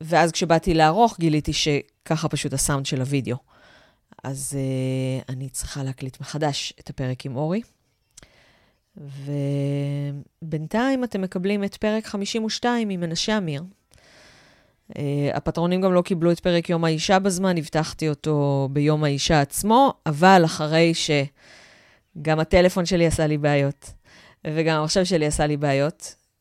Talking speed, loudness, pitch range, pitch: 130 wpm, -22 LUFS, 140-180 Hz, 155 Hz